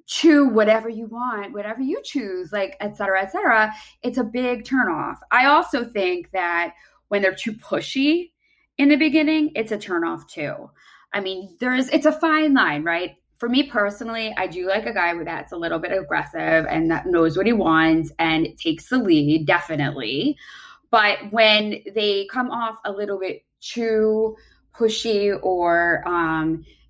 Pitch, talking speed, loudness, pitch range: 215 Hz, 175 wpm, -21 LUFS, 180-250 Hz